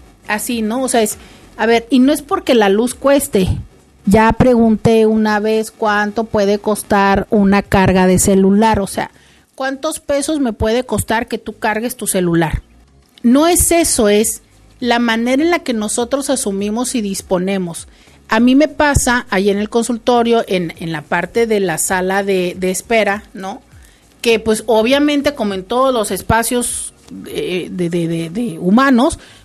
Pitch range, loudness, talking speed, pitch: 195-245 Hz, -14 LUFS, 170 wpm, 220 Hz